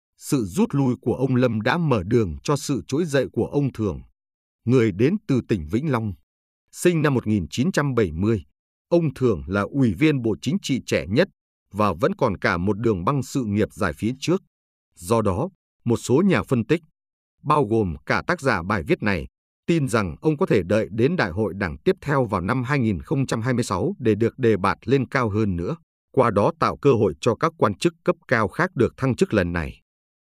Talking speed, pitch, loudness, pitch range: 205 wpm, 115 Hz, -22 LUFS, 100-140 Hz